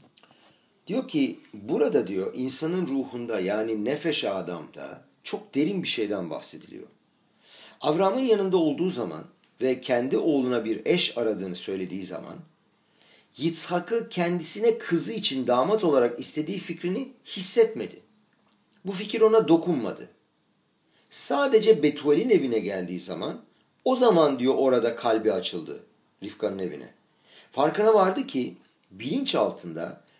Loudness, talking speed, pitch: -25 LUFS, 115 wpm, 165 Hz